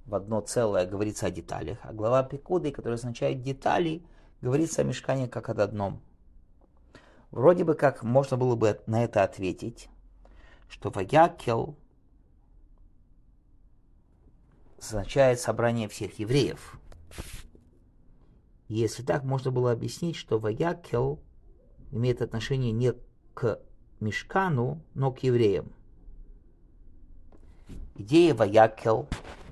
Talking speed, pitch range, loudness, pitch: 100 wpm, 90-135 Hz, -27 LUFS, 115 Hz